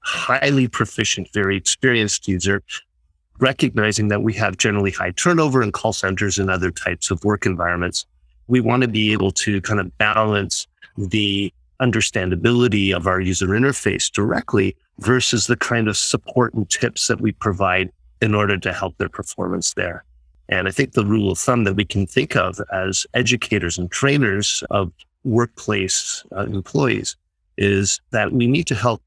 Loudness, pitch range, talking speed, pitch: -19 LUFS, 95-115 Hz, 165 wpm, 100 Hz